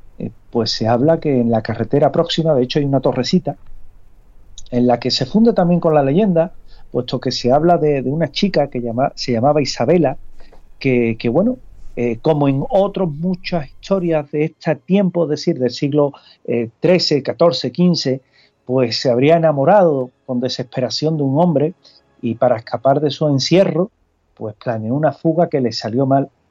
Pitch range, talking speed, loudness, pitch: 120-165 Hz, 175 wpm, -17 LUFS, 140 Hz